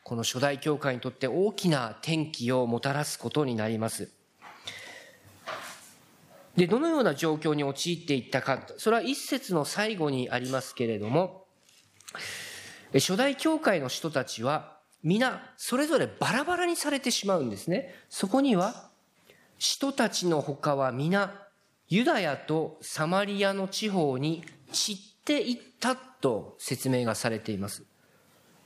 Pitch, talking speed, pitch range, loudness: 165 Hz, 270 characters per minute, 135-225 Hz, -29 LUFS